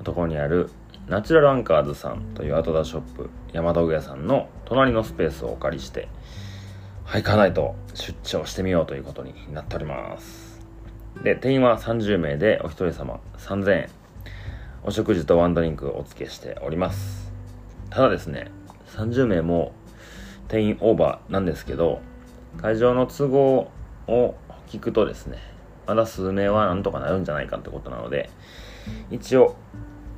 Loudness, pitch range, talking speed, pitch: -23 LUFS, 85-110 Hz, 320 characters per minute, 100 Hz